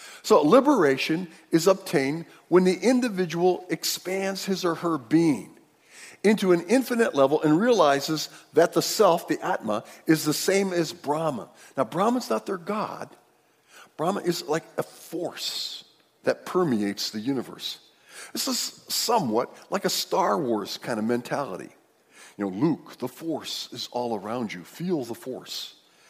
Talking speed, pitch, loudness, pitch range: 145 wpm, 170 Hz, -25 LUFS, 140-195 Hz